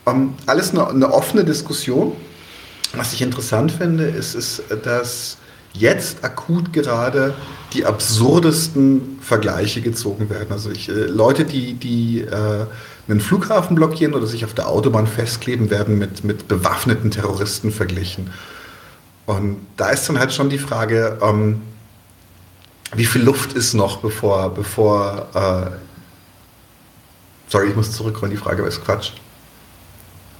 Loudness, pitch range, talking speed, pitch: -18 LUFS, 100-125 Hz, 135 wpm, 110 Hz